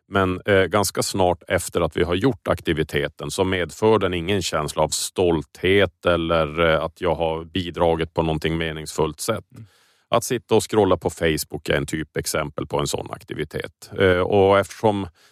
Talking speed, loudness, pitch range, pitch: 170 wpm, -22 LUFS, 80-95 Hz, 85 Hz